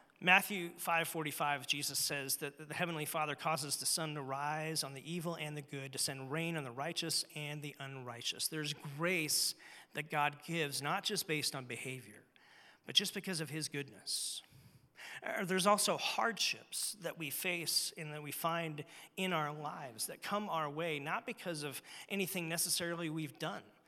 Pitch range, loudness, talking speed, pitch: 145-175 Hz, -37 LUFS, 170 wpm, 155 Hz